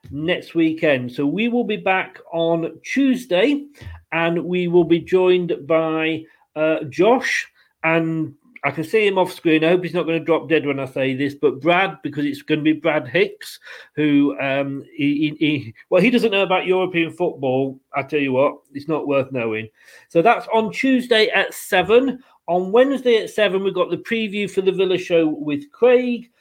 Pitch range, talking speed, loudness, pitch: 150-195 Hz, 195 wpm, -19 LUFS, 165 Hz